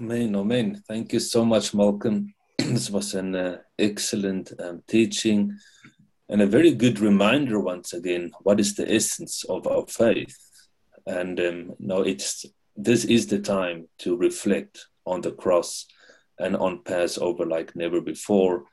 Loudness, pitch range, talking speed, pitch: -24 LUFS, 95-115 Hz, 150 wpm, 100 Hz